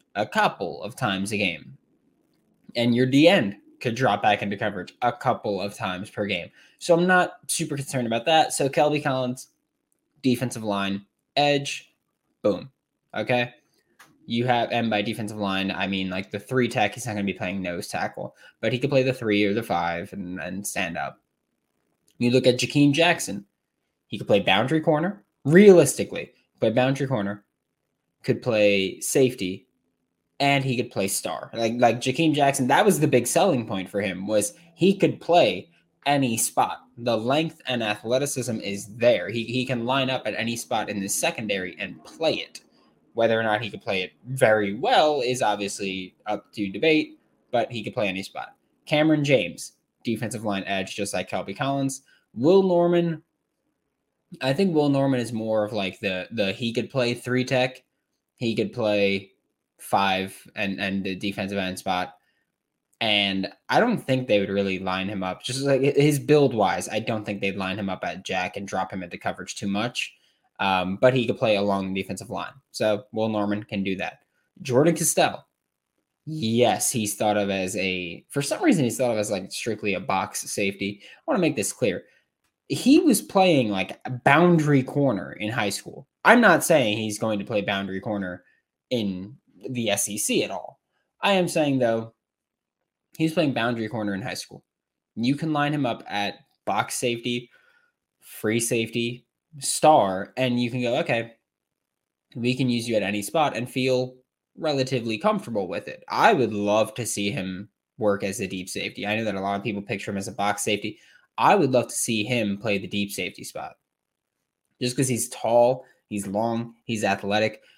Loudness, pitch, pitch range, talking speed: -24 LUFS, 115 Hz, 100-130 Hz, 185 wpm